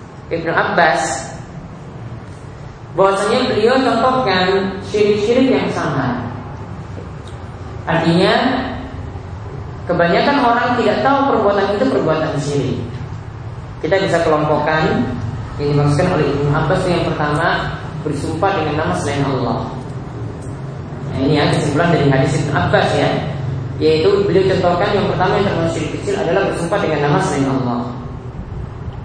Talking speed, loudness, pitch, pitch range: 115 wpm, -16 LUFS, 150 Hz, 130-180 Hz